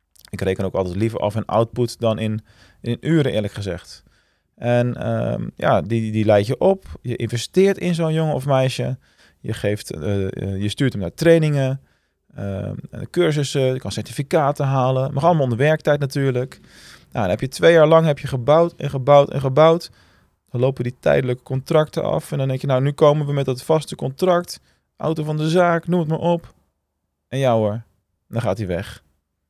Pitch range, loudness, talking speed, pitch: 105-150 Hz, -20 LUFS, 200 wpm, 130 Hz